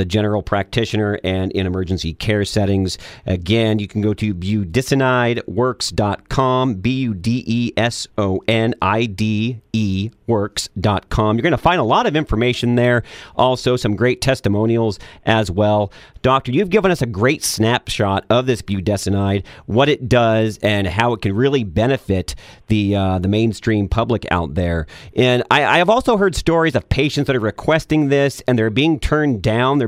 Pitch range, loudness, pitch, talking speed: 100-125 Hz, -18 LUFS, 110 Hz, 170 wpm